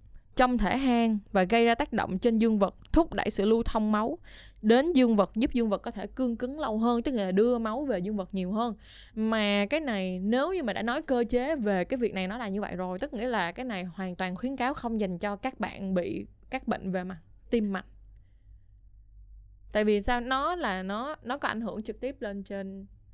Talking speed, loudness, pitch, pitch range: 240 wpm, -29 LUFS, 215 Hz, 190-245 Hz